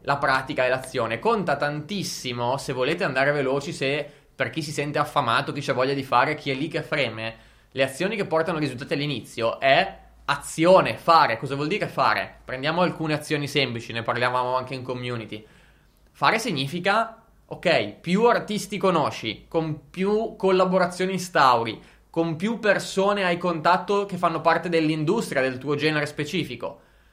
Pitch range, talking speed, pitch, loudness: 135-180 Hz, 155 wpm, 150 Hz, -24 LUFS